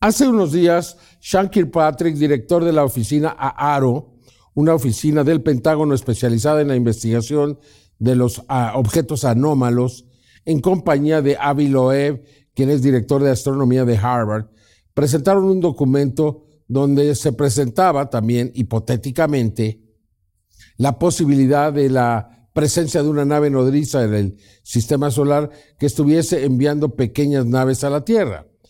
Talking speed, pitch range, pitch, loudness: 135 wpm, 125-150 Hz, 140 Hz, -17 LUFS